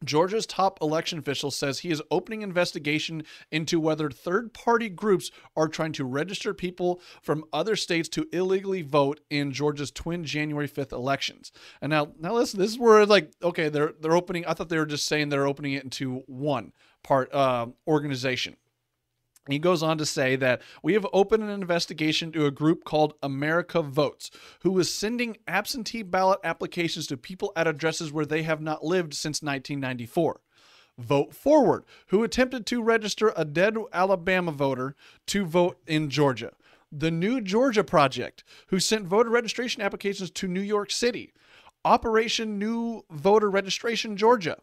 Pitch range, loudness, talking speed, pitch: 150-200 Hz, -26 LUFS, 165 wpm, 170 Hz